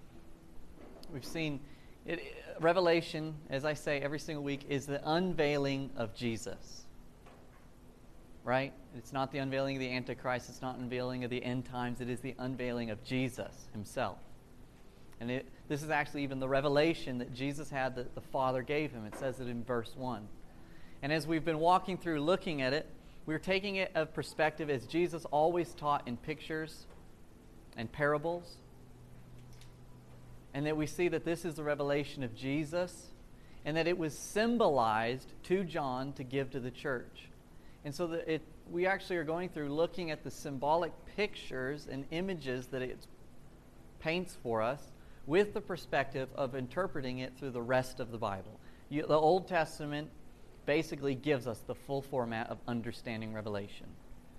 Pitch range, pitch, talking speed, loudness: 125-160 Hz, 140 Hz, 165 wpm, -36 LUFS